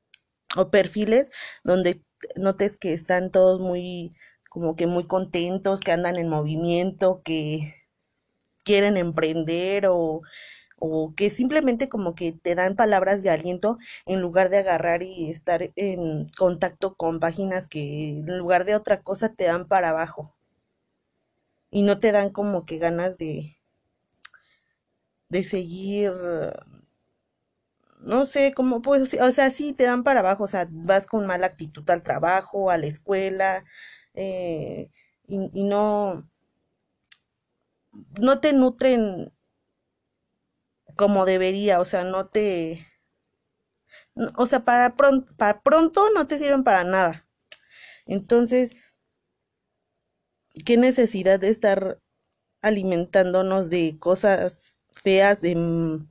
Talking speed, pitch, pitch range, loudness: 125 wpm, 190 Hz, 170-205 Hz, -23 LUFS